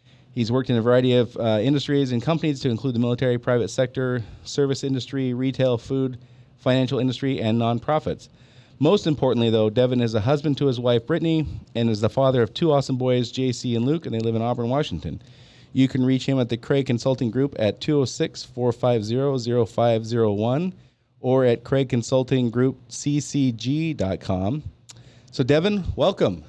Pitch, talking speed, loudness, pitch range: 125 Hz, 165 wpm, -22 LUFS, 120-135 Hz